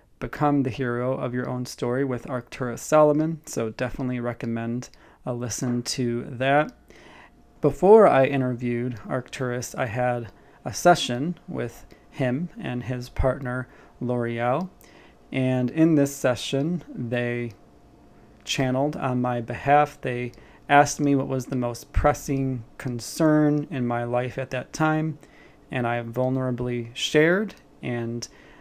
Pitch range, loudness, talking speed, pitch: 120-145 Hz, -24 LUFS, 125 wpm, 125 Hz